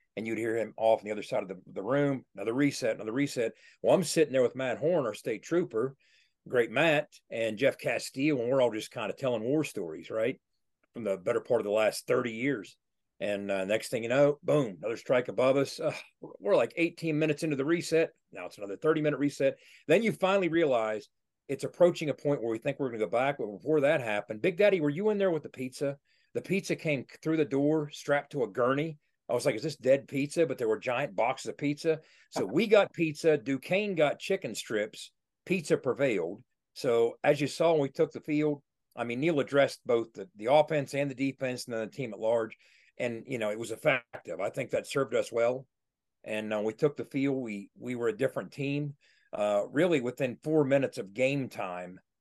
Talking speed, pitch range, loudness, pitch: 225 wpm, 120-155 Hz, -30 LUFS, 140 Hz